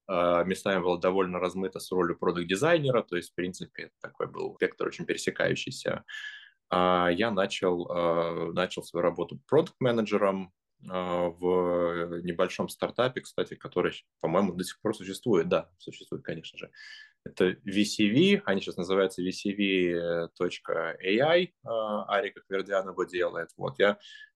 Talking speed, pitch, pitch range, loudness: 140 wpm, 95 Hz, 90-110 Hz, -29 LUFS